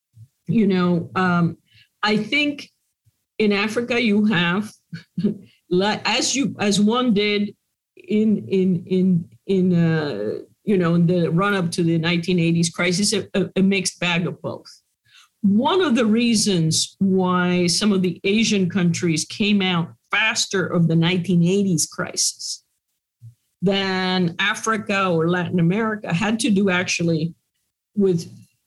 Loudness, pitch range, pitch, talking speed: -20 LUFS, 170-205 Hz, 185 Hz, 130 wpm